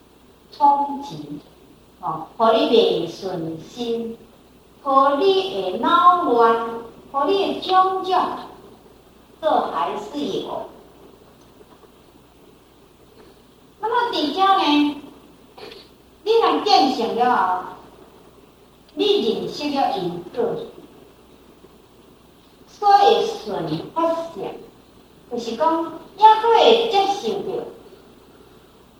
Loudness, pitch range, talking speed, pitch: -19 LUFS, 240-400 Hz, 110 characters per minute, 330 Hz